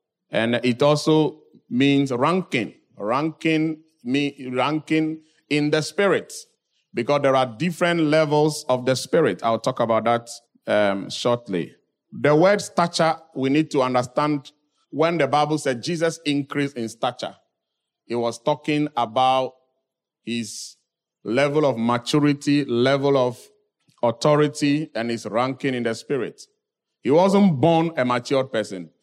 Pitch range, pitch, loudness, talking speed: 125-155 Hz, 145 Hz, -22 LUFS, 130 wpm